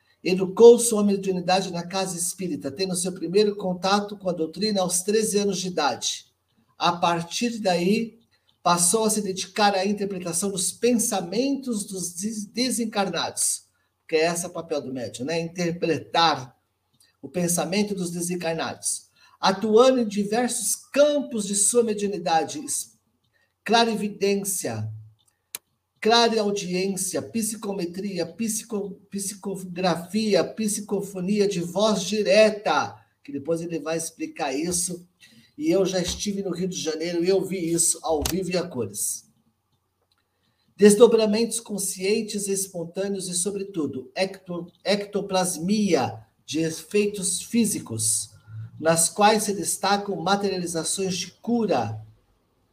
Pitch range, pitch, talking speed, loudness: 165-205 Hz, 190 Hz, 115 wpm, -24 LUFS